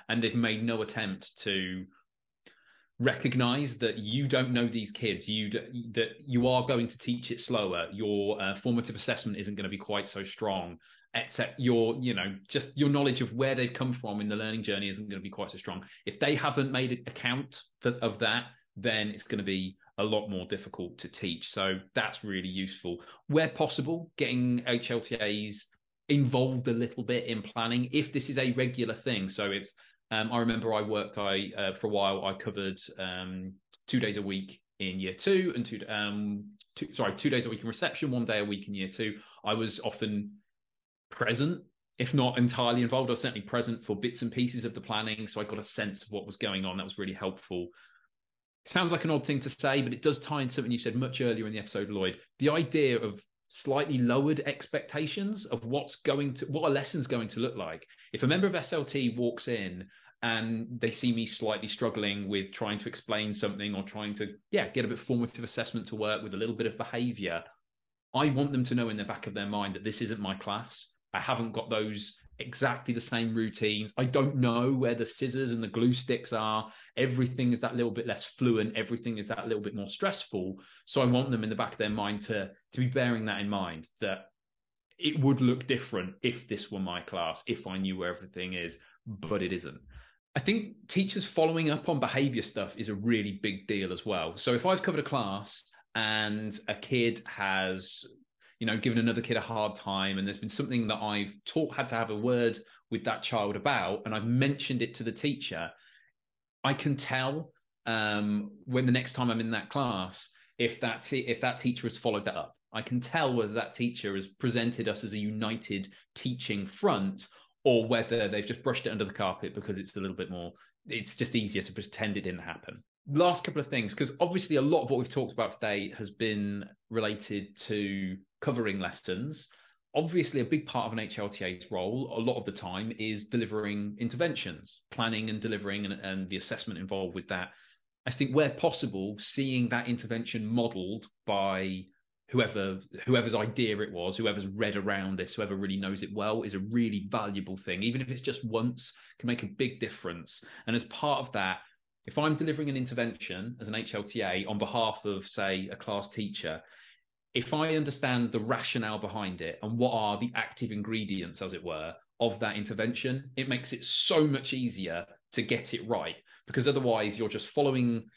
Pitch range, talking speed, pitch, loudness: 105-125 Hz, 205 wpm, 115 Hz, -32 LUFS